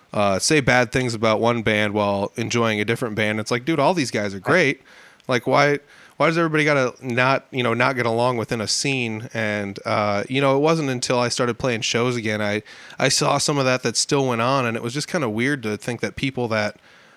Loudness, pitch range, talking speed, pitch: -21 LUFS, 110-135 Hz, 240 wpm, 120 Hz